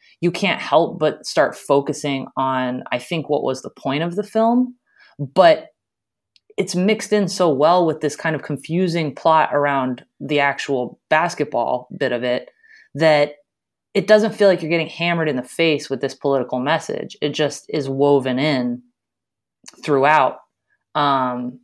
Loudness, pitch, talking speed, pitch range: -19 LUFS, 150 Hz, 160 wpm, 135-175 Hz